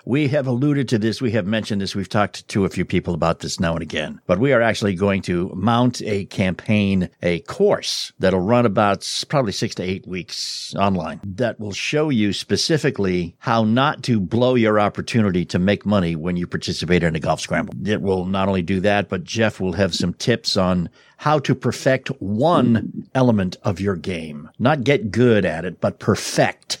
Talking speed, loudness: 200 wpm, -20 LUFS